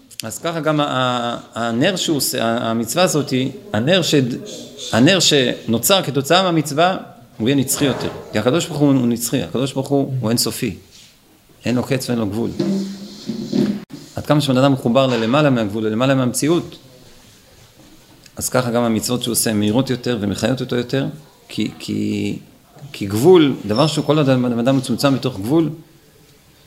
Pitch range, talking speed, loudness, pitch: 115-150 Hz, 145 wpm, -18 LUFS, 130 Hz